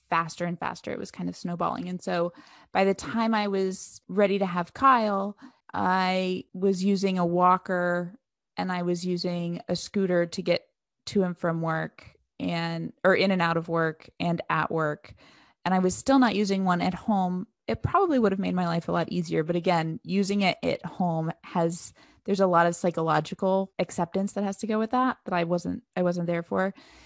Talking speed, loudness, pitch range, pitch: 200 wpm, -27 LUFS, 170-195 Hz, 180 Hz